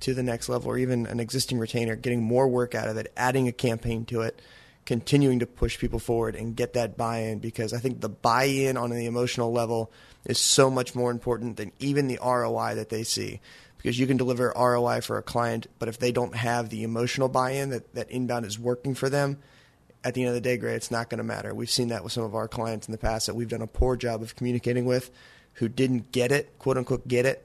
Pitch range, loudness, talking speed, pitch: 115-125 Hz, -27 LUFS, 250 wpm, 120 Hz